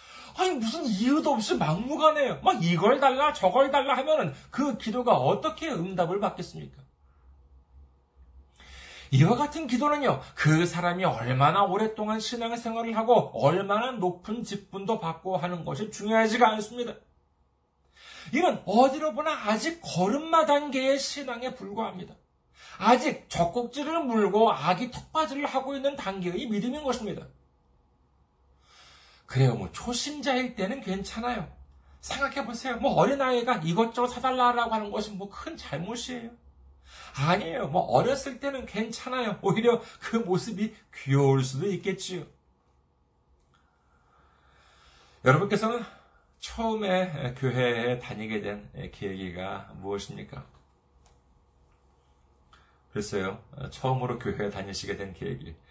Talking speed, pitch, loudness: 280 characters per minute, 195 Hz, -27 LUFS